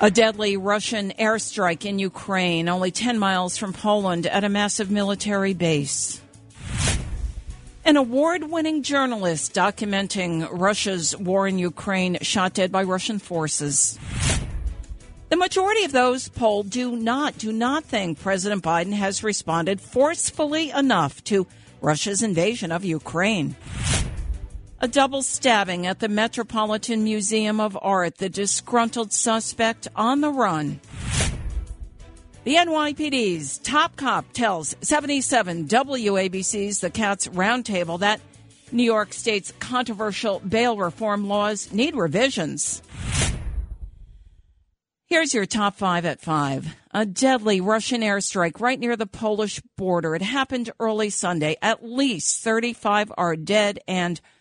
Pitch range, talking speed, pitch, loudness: 175-230 Hz, 120 wpm, 205 Hz, -23 LUFS